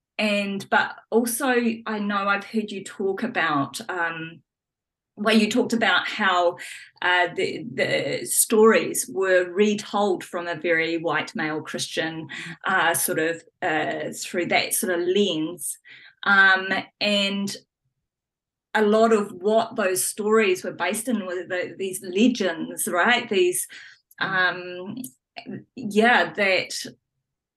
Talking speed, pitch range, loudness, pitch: 125 wpm, 175-220 Hz, -22 LUFS, 195 Hz